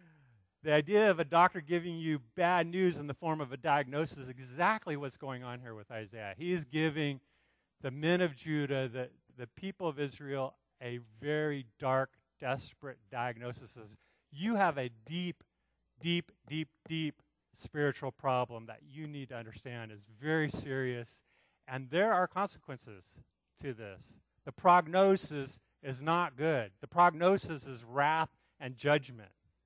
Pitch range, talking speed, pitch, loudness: 125-165 Hz, 150 wpm, 145 Hz, -34 LUFS